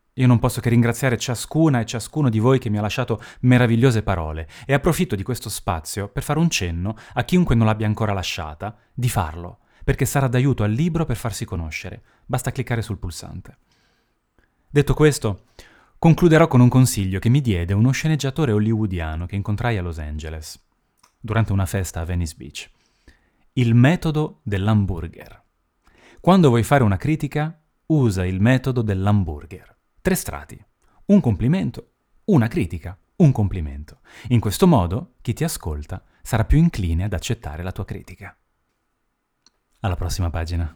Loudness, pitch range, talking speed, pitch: -20 LUFS, 90-130 Hz, 155 wpm, 110 Hz